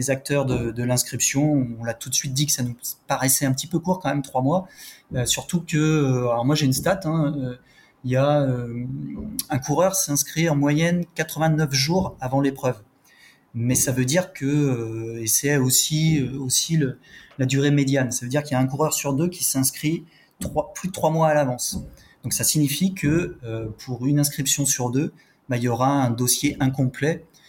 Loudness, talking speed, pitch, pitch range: -22 LUFS, 210 wpm, 140 Hz, 130-155 Hz